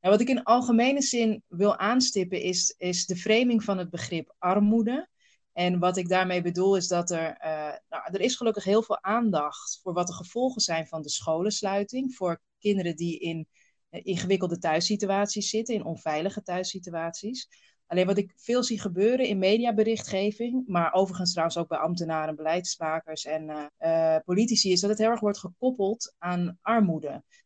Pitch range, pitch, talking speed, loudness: 170-220 Hz, 190 Hz, 175 wpm, -27 LUFS